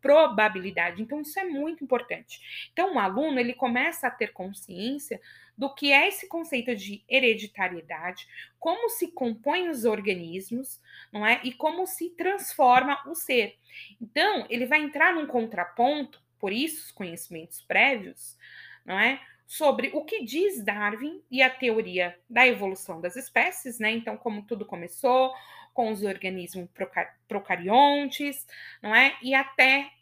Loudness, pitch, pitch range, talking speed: -25 LUFS, 250 Hz, 210-290 Hz, 145 wpm